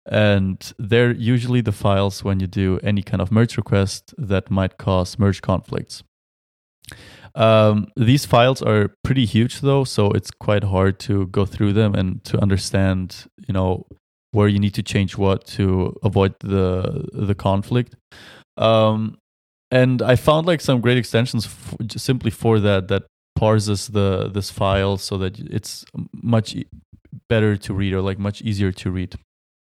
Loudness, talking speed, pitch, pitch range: -20 LUFS, 160 wpm, 105 Hz, 95-115 Hz